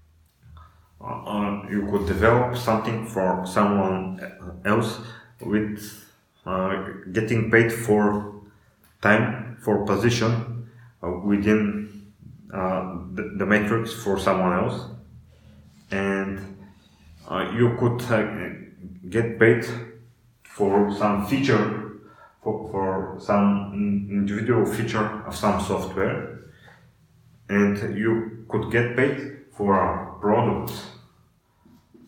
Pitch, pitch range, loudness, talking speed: 105 Hz, 100-115 Hz, -24 LUFS, 95 wpm